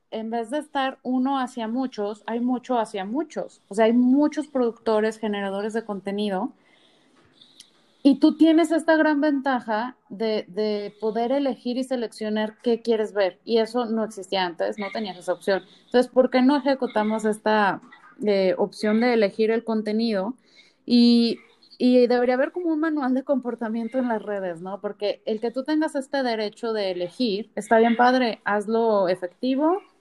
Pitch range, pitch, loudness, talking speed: 210-255 Hz, 230 Hz, -23 LUFS, 165 wpm